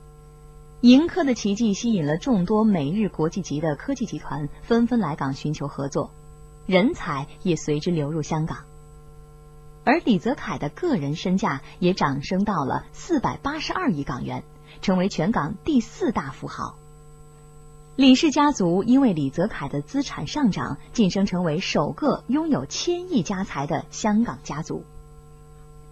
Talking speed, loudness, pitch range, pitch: 230 characters per minute, -23 LUFS, 150-230 Hz, 170 Hz